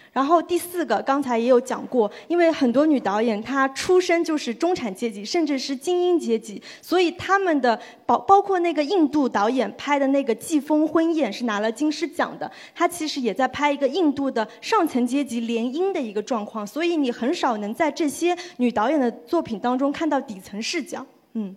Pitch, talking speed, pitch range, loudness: 275 Hz, 305 characters per minute, 235-330 Hz, -22 LUFS